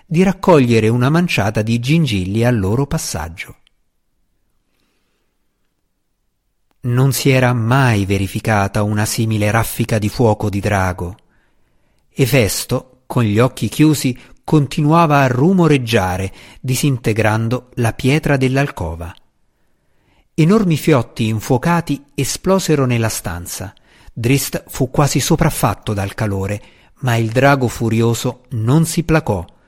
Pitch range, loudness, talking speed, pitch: 110-145 Hz, -16 LUFS, 105 wpm, 120 Hz